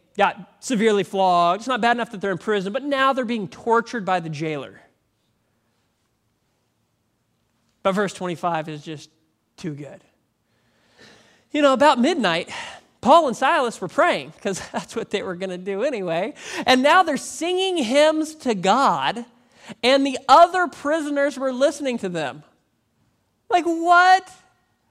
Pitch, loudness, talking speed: 215 Hz, -20 LUFS, 145 wpm